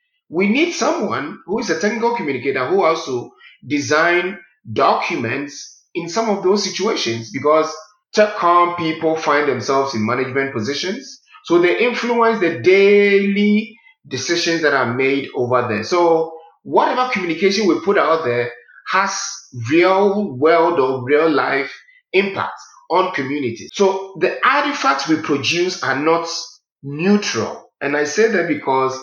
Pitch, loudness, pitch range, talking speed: 175 Hz, -17 LUFS, 145-210 Hz, 135 wpm